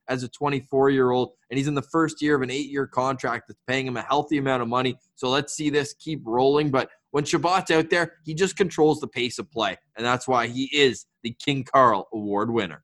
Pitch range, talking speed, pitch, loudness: 125-150 Hz, 245 wpm, 135 Hz, -24 LUFS